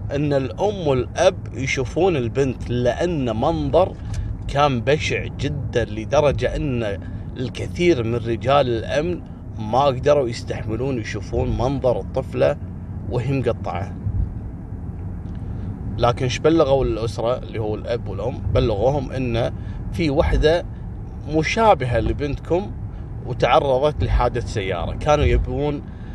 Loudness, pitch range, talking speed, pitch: -21 LUFS, 100-135 Hz, 95 wpm, 115 Hz